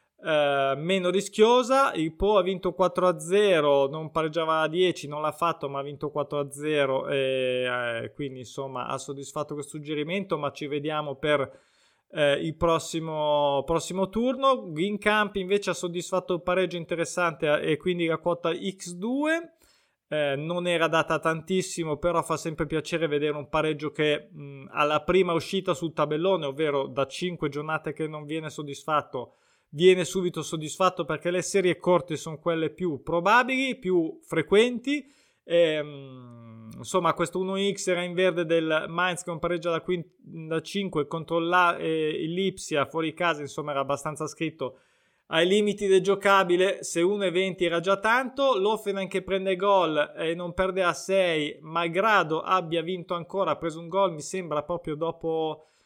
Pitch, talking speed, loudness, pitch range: 165 Hz, 160 wpm, -26 LUFS, 150-185 Hz